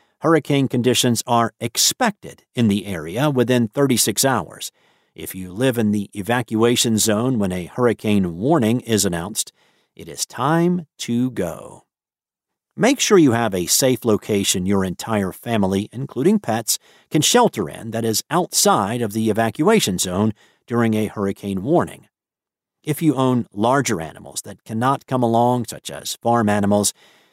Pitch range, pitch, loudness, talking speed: 100-130 Hz, 115 Hz, -19 LUFS, 145 wpm